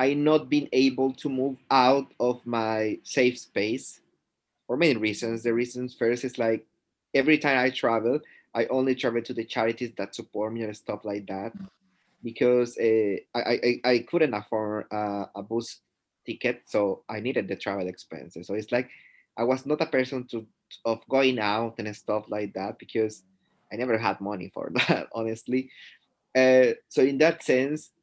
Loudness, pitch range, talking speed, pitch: -26 LUFS, 105-130 Hz, 175 wpm, 115 Hz